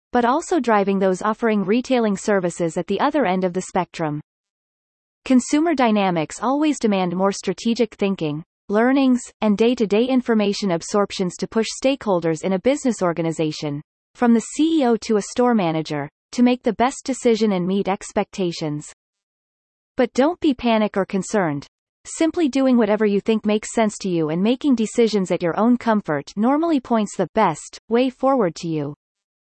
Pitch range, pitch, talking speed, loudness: 185-245 Hz, 210 Hz, 165 wpm, -20 LUFS